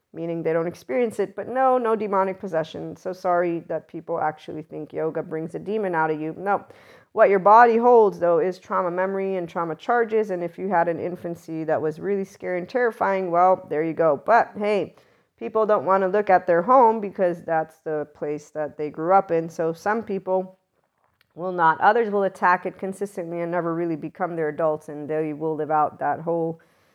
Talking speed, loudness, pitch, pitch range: 205 wpm, -23 LUFS, 175 Hz, 160-195 Hz